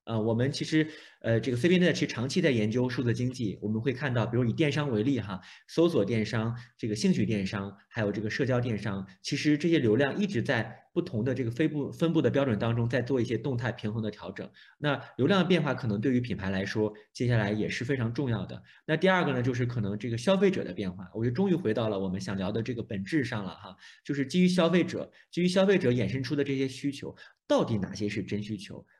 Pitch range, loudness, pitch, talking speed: 105-145 Hz, -29 LUFS, 120 Hz, 370 characters per minute